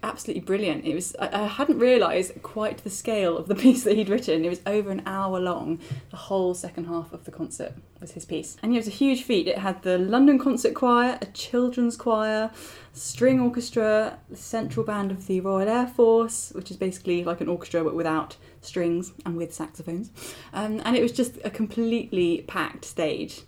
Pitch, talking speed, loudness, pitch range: 200 Hz, 200 wpm, -25 LUFS, 175-230 Hz